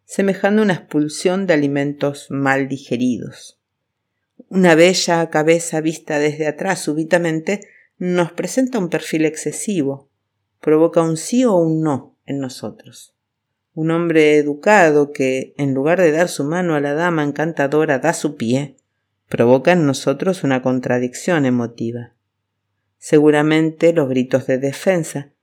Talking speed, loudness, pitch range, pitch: 130 wpm, -17 LUFS, 130-170 Hz, 150 Hz